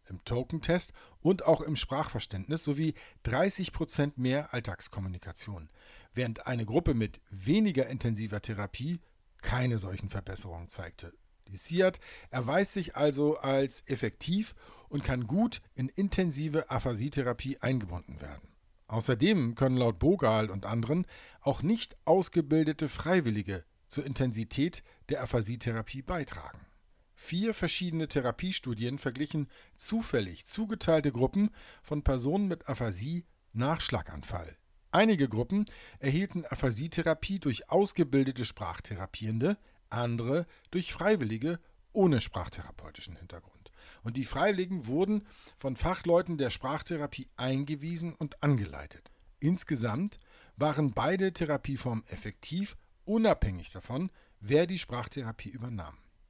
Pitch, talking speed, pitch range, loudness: 135 Hz, 105 wpm, 110-165 Hz, -32 LUFS